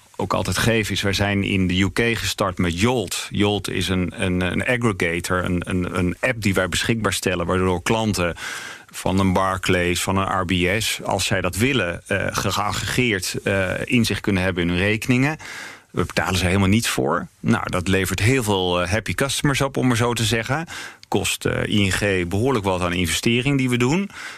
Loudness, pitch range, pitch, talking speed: -21 LUFS, 95-115 Hz, 100 Hz, 180 wpm